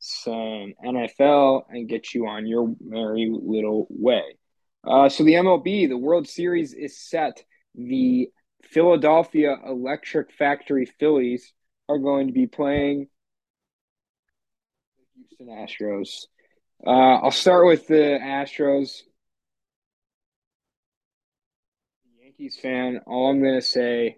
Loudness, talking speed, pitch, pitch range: -21 LUFS, 110 wpm, 140 Hz, 125-160 Hz